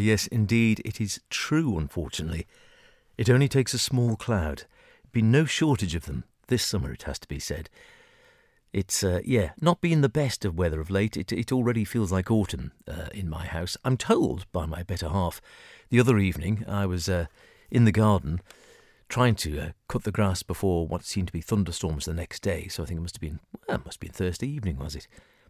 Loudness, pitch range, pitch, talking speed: -27 LUFS, 85-120 Hz, 100 Hz, 215 wpm